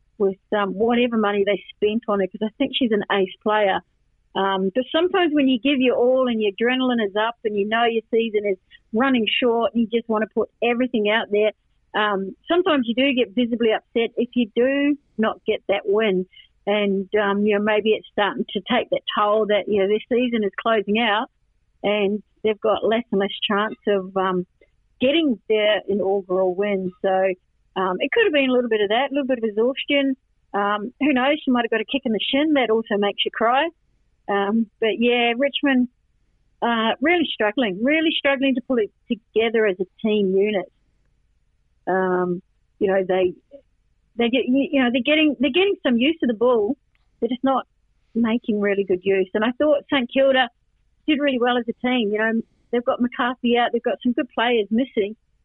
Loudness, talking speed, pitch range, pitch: -21 LUFS, 205 wpm, 205-255 Hz, 225 Hz